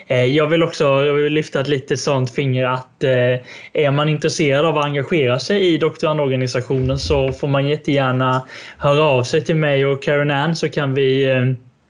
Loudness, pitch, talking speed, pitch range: -17 LUFS, 140 Hz, 180 wpm, 130-155 Hz